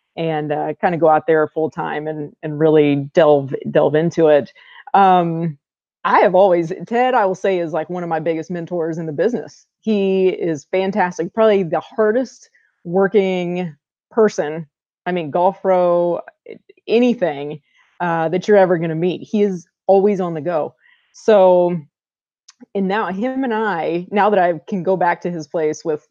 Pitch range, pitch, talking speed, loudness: 160-195 Hz, 175 Hz, 175 wpm, -17 LUFS